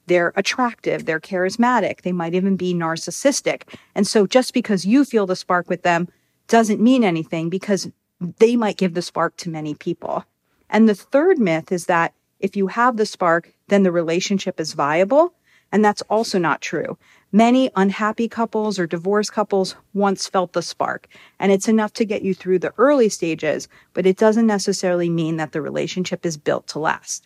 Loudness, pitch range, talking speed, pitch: -19 LUFS, 175-215 Hz, 185 wpm, 190 Hz